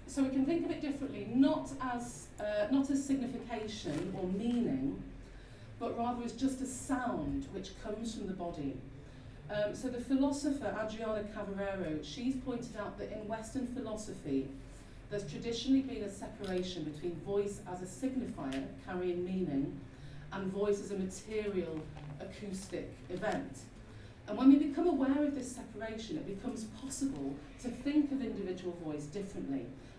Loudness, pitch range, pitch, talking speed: -37 LUFS, 170-255 Hz, 215 Hz, 150 wpm